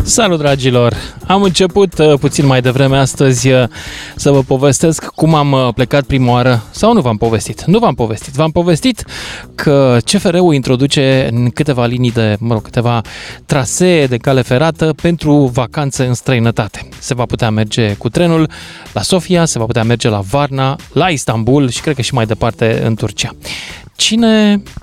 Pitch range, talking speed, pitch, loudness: 120-155 Hz, 165 wpm, 135 Hz, -12 LUFS